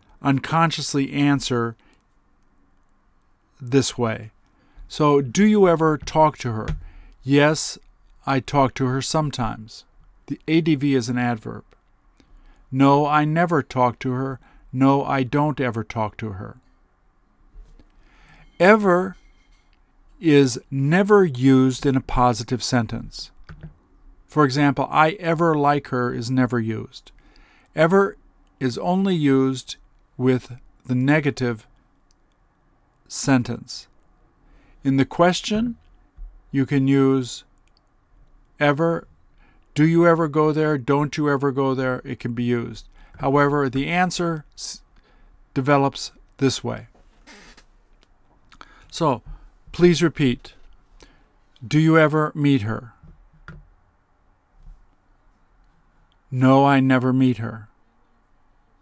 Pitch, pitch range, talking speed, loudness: 135 Hz, 115-150 Hz, 100 wpm, -20 LUFS